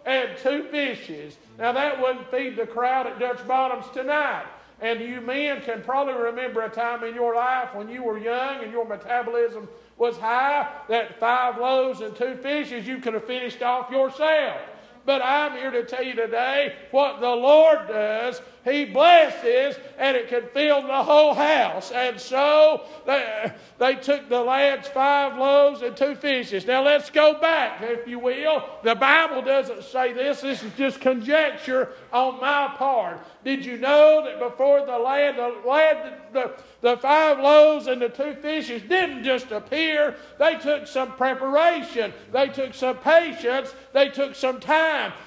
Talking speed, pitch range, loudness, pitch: 170 wpm, 245-285 Hz, -22 LUFS, 260 Hz